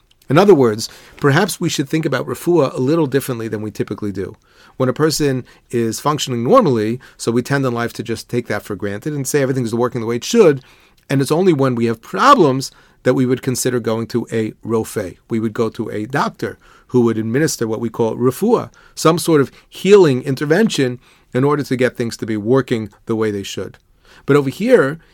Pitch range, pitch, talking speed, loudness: 115-140 Hz, 125 Hz, 215 wpm, -17 LUFS